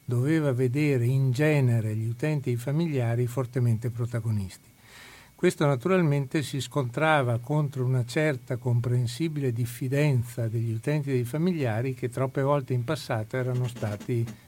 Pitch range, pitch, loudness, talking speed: 120-145 Hz, 130 Hz, -27 LUFS, 135 wpm